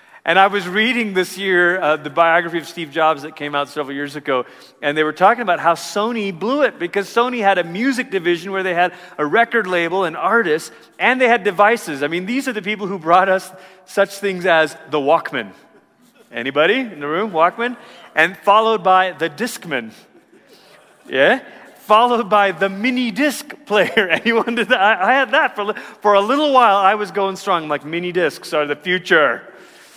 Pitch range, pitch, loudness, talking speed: 170-225 Hz, 190 Hz, -17 LUFS, 195 wpm